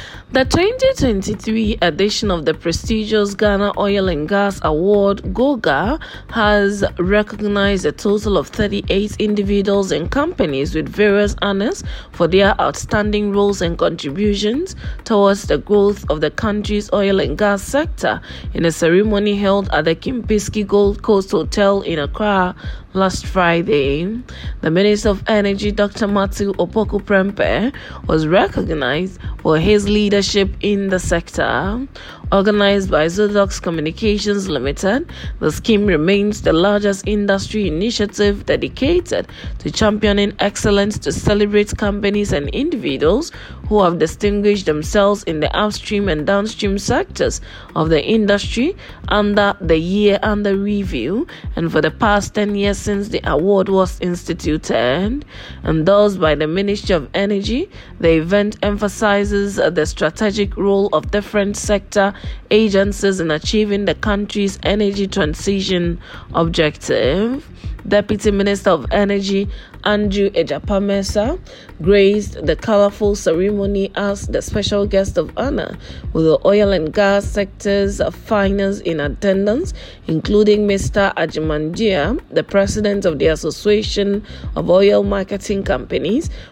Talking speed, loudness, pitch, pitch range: 125 wpm, -17 LUFS, 200 Hz, 190-210 Hz